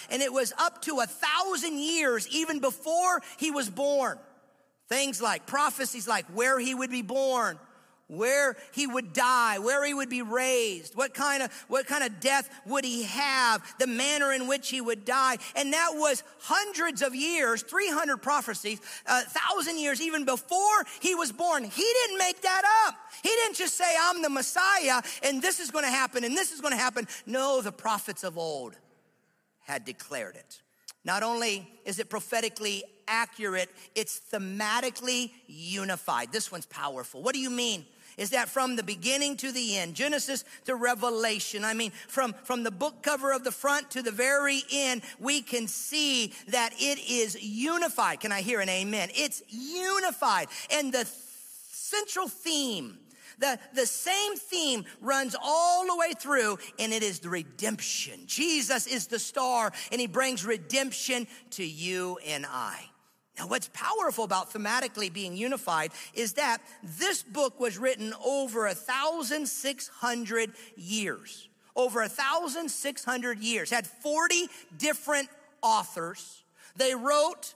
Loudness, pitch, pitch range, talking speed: -28 LUFS, 260 Hz, 225-290 Hz, 165 wpm